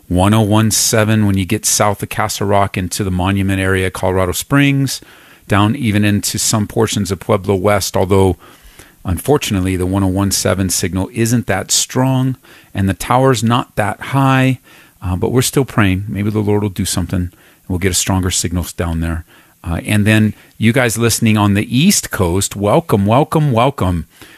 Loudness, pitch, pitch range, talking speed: -15 LUFS, 105 Hz, 95-115 Hz, 165 wpm